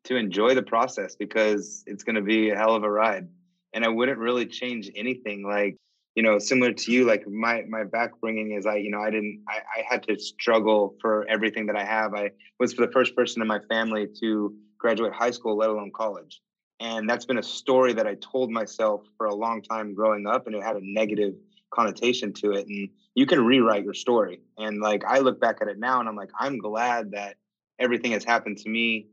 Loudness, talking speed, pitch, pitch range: -25 LUFS, 225 wpm, 110 Hz, 105-120 Hz